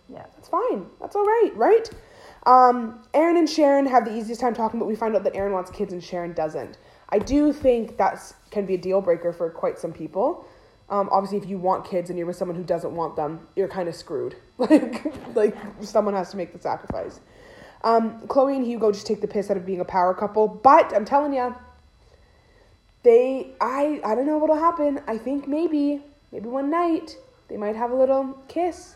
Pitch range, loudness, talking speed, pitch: 195-285 Hz, -23 LUFS, 215 wpm, 230 Hz